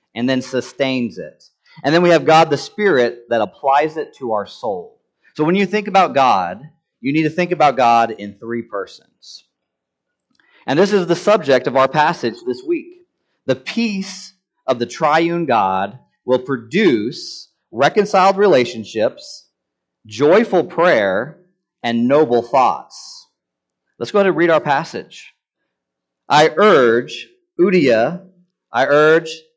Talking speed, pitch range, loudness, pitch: 140 wpm, 120-185 Hz, -16 LUFS, 150 Hz